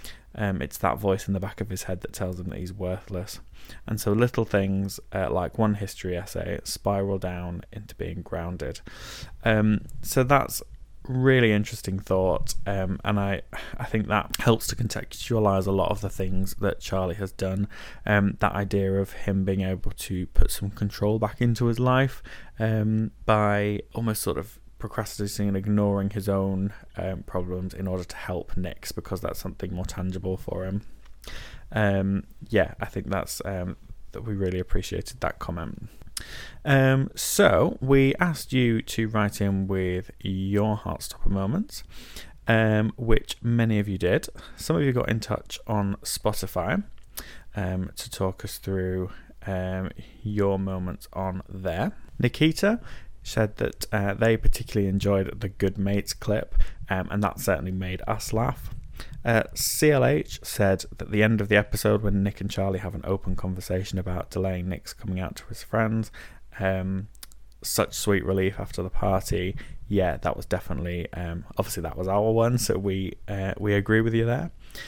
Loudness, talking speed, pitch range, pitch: -27 LUFS, 165 wpm, 95-110 Hz, 100 Hz